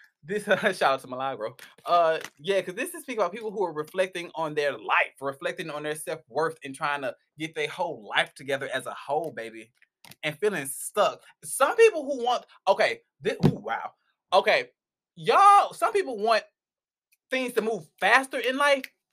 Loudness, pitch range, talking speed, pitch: -26 LUFS, 150-250 Hz, 180 wpm, 185 Hz